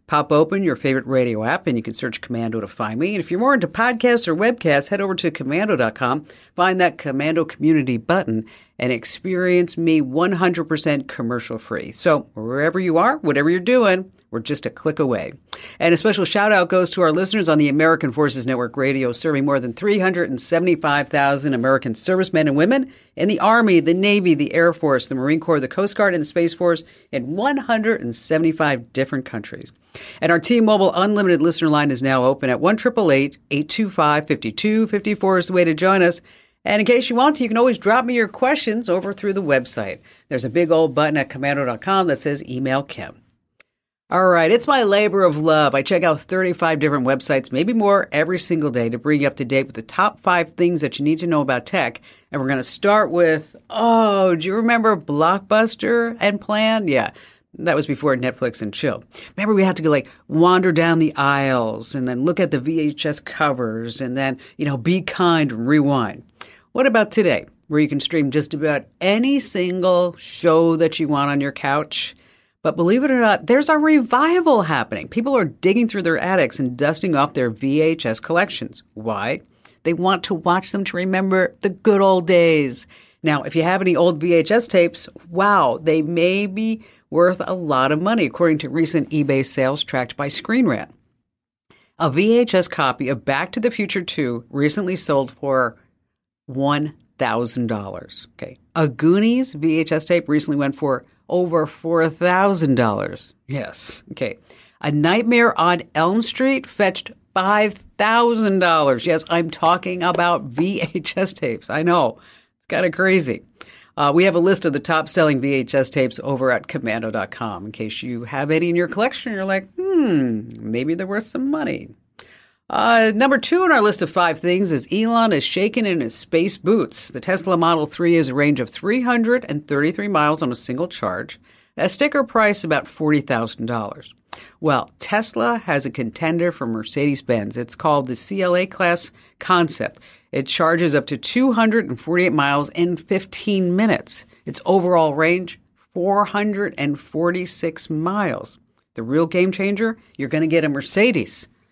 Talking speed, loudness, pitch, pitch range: 180 wpm, -19 LUFS, 165 Hz, 140-195 Hz